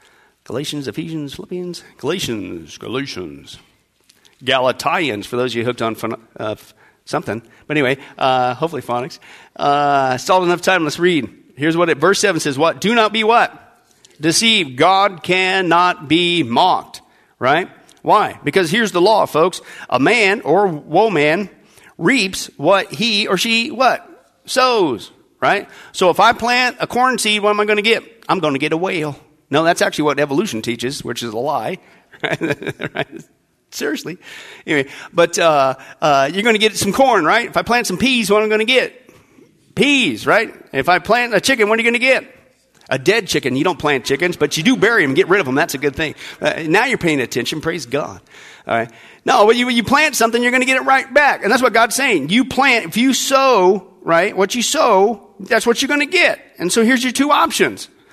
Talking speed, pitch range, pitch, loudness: 205 wpm, 150-235 Hz, 190 Hz, -15 LUFS